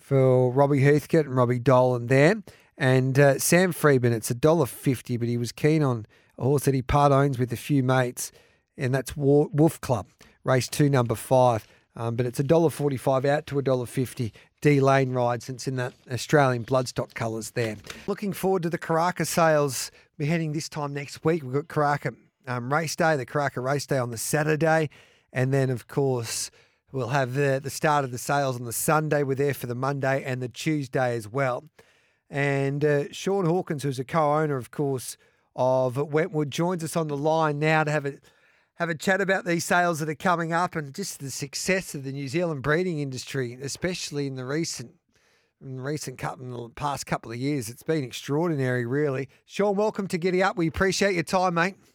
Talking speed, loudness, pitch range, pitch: 195 wpm, -25 LUFS, 130-160 Hz, 140 Hz